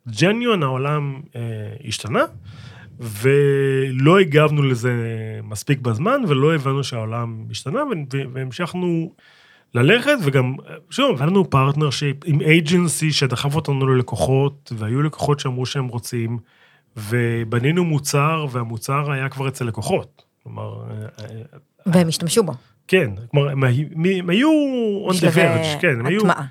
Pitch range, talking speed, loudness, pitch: 120-160 Hz, 105 wpm, -19 LUFS, 140 Hz